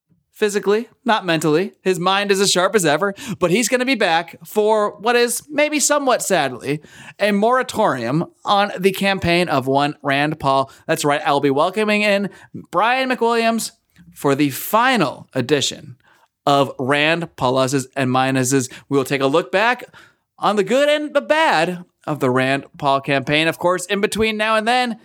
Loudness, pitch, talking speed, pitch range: -18 LUFS, 185 Hz, 175 wpm, 145-215 Hz